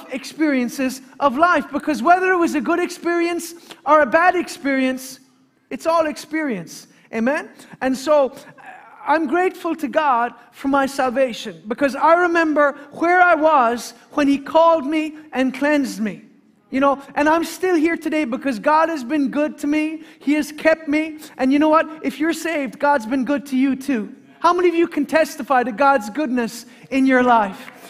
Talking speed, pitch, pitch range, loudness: 180 wpm, 290 Hz, 260-320 Hz, -19 LUFS